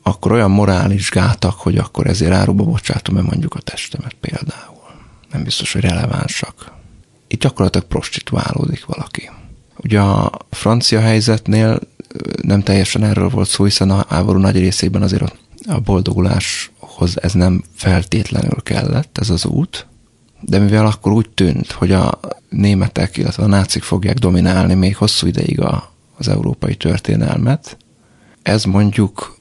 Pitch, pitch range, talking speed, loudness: 100 Hz, 95-110 Hz, 135 wpm, -15 LUFS